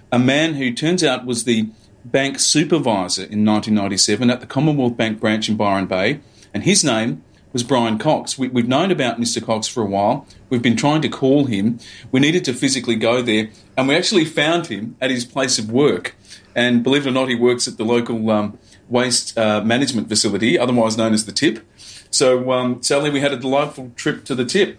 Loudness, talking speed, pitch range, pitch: -18 LUFS, 210 wpm, 110-130 Hz, 120 Hz